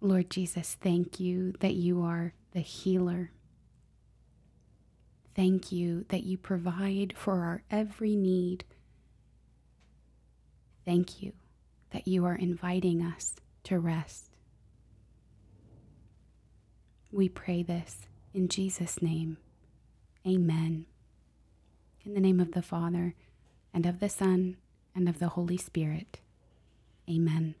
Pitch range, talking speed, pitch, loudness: 120-185 Hz, 110 wpm, 175 Hz, -32 LUFS